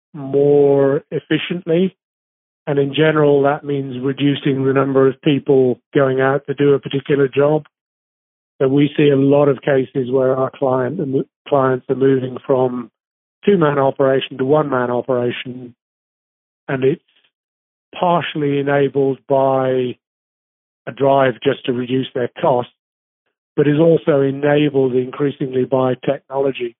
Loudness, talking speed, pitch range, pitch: -17 LUFS, 130 wpm, 130-145 Hz, 135 Hz